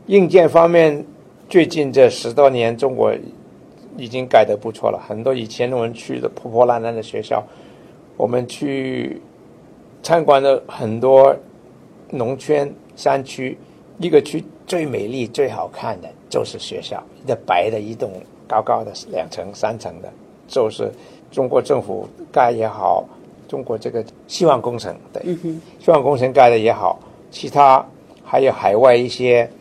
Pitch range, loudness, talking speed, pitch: 120-165 Hz, -17 LUFS, 215 characters per minute, 135 Hz